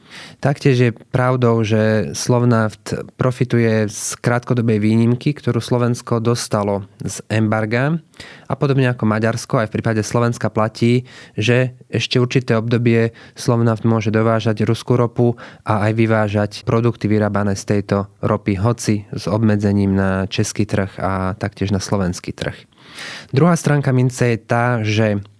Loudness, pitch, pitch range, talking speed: -18 LUFS, 115 Hz, 105-125 Hz, 135 wpm